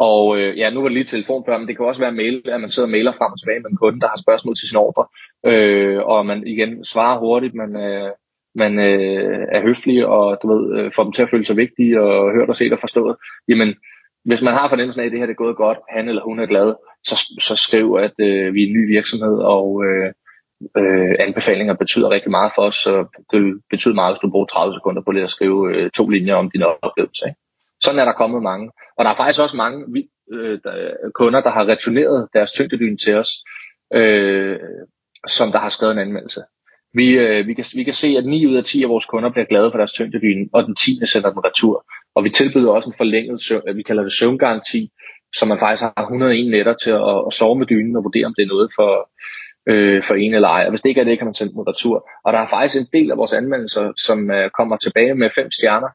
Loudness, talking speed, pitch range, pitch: -16 LUFS, 250 wpm, 105-125 Hz, 115 Hz